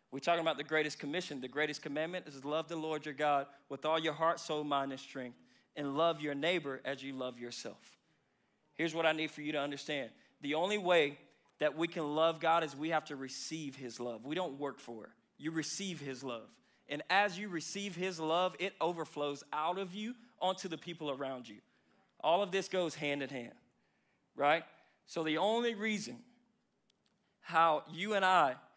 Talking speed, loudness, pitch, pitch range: 200 wpm, -36 LUFS, 155 Hz, 145-180 Hz